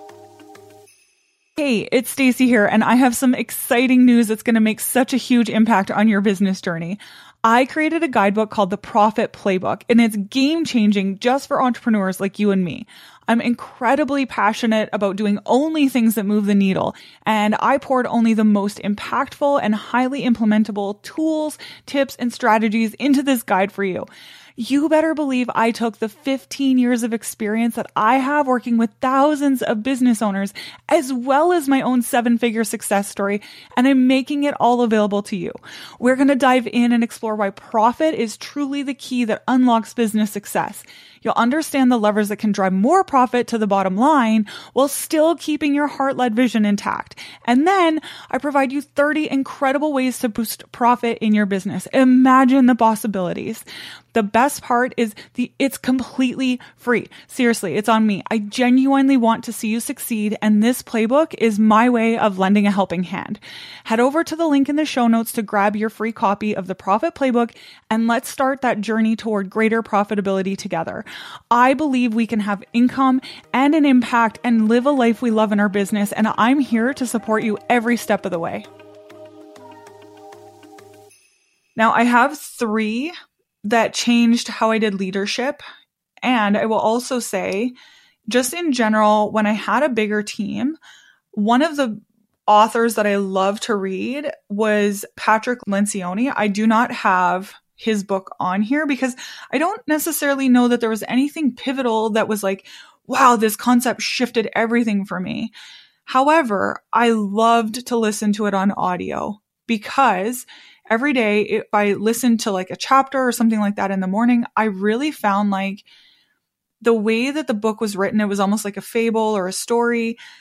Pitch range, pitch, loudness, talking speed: 210-260 Hz, 230 Hz, -18 LUFS, 175 wpm